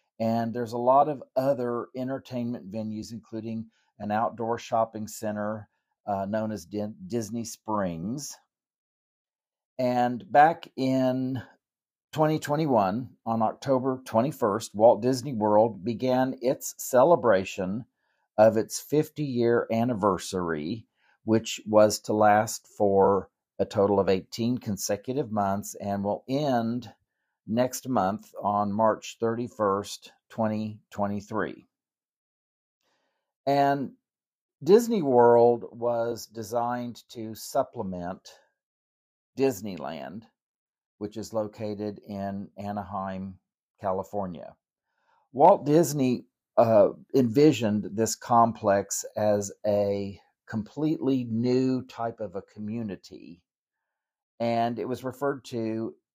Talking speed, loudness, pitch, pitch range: 95 wpm, -26 LUFS, 115 Hz, 105-125 Hz